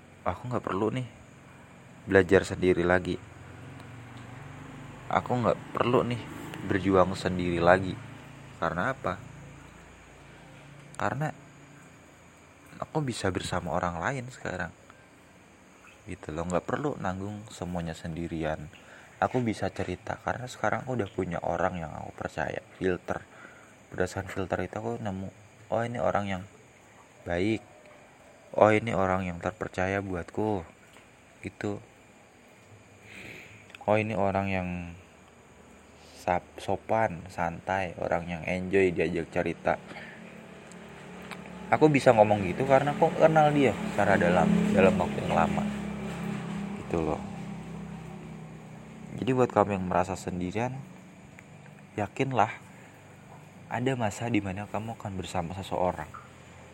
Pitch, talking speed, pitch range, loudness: 105 Hz, 105 wpm, 90-130 Hz, -29 LUFS